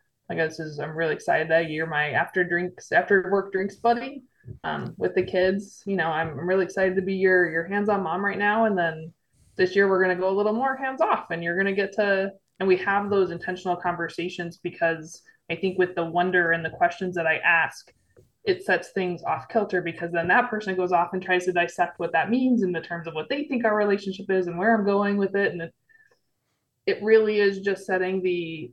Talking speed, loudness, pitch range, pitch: 235 wpm, -24 LUFS, 170-200 Hz, 185 Hz